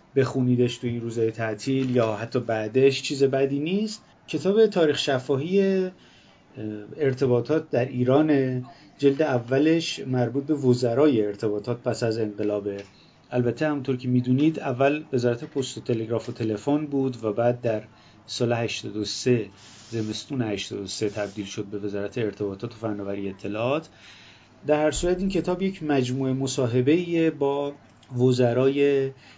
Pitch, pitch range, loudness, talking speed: 125 Hz, 110-140 Hz, -25 LUFS, 130 wpm